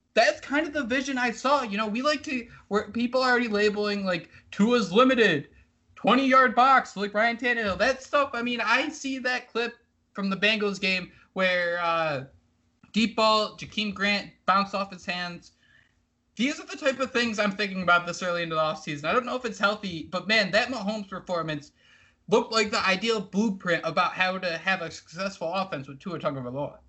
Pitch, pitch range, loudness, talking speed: 210 Hz, 180-245 Hz, -25 LUFS, 195 wpm